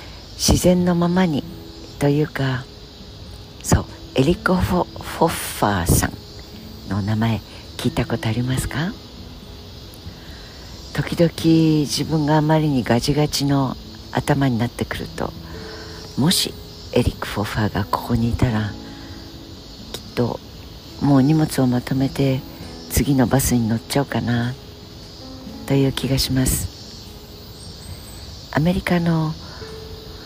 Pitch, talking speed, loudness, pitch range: 115 Hz, 235 characters per minute, -20 LUFS, 95-140 Hz